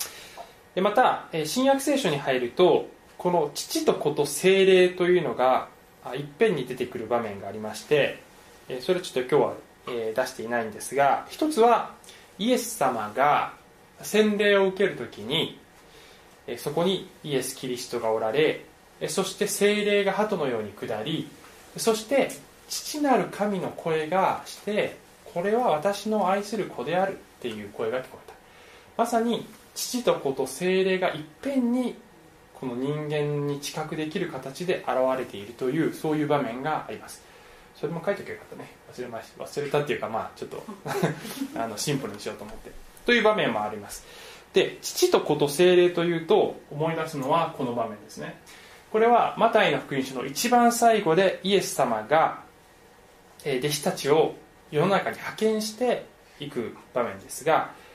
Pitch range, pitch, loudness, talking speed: 150-225 Hz, 190 Hz, -25 LUFS, 310 characters per minute